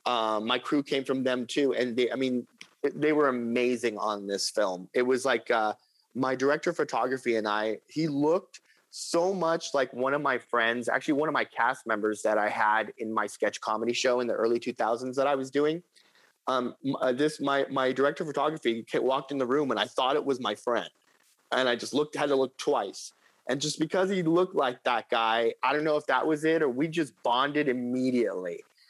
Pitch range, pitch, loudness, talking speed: 120-150 Hz, 130 Hz, -28 LUFS, 215 wpm